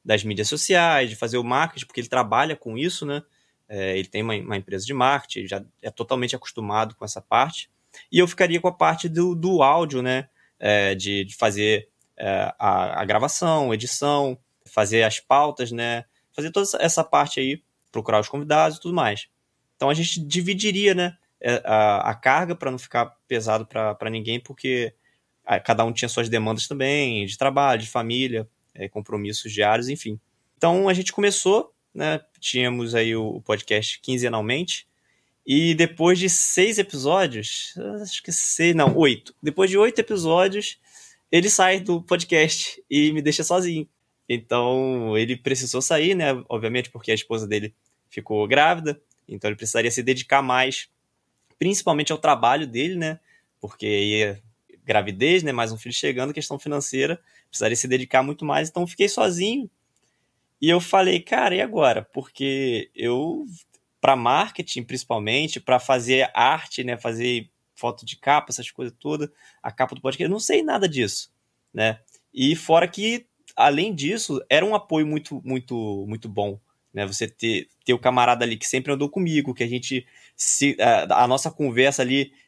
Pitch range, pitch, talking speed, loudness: 115-160 Hz, 130 Hz, 165 wpm, -22 LUFS